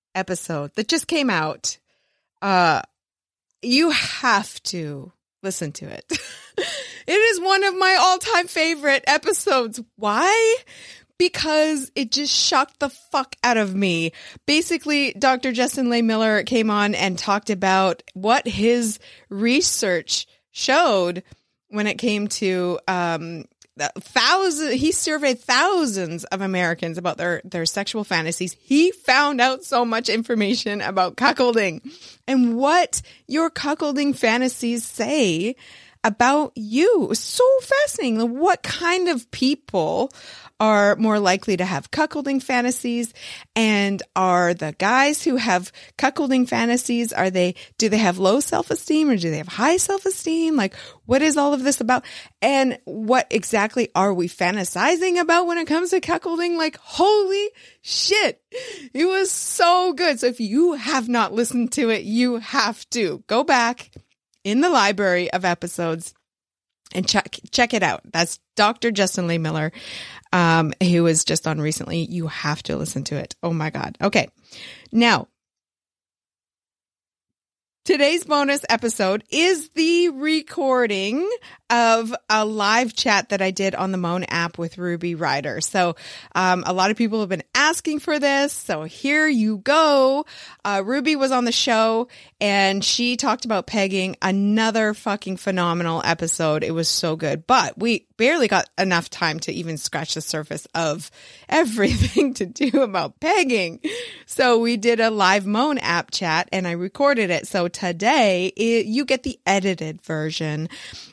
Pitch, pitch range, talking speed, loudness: 225 Hz, 185-285 Hz, 150 wpm, -20 LUFS